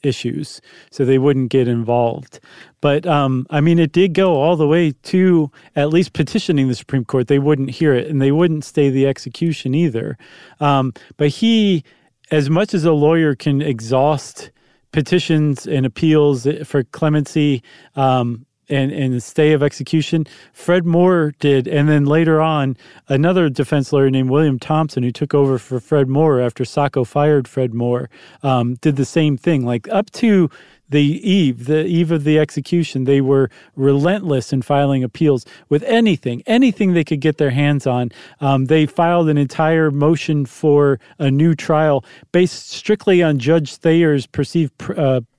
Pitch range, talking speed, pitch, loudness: 135-160 Hz, 170 wpm, 145 Hz, -16 LUFS